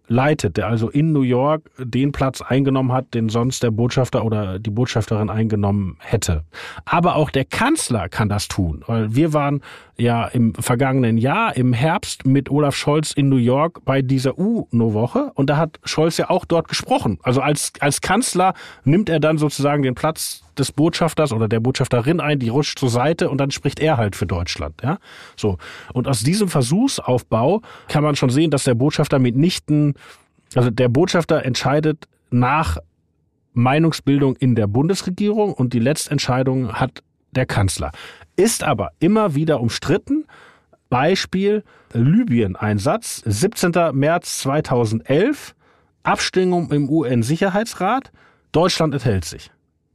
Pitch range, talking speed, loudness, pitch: 120-155 Hz, 150 wpm, -19 LUFS, 135 Hz